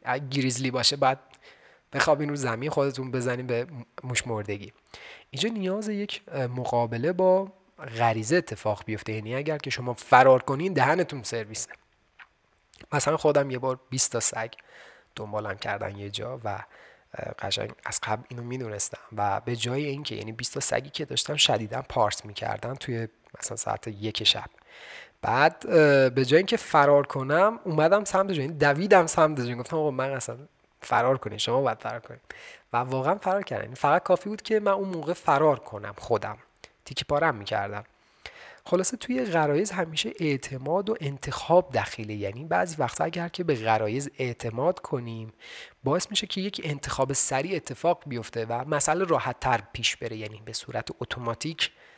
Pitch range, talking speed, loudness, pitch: 120-160 Hz, 160 wpm, -26 LUFS, 135 Hz